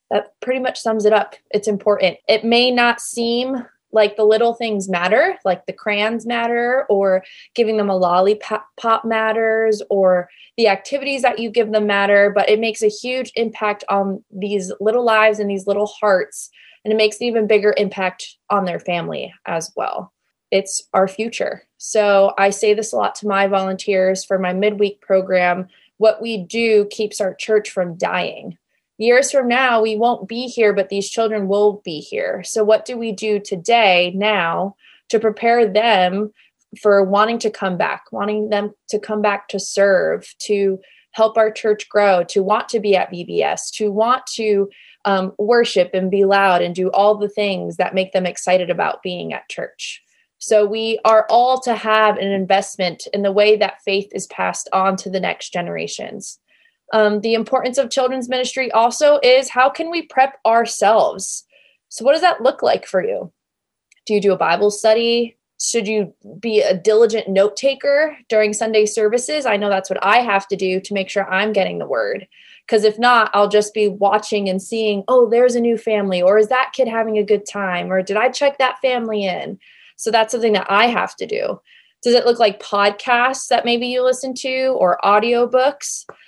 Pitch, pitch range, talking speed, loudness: 215 Hz, 200-235 Hz, 190 wpm, -17 LUFS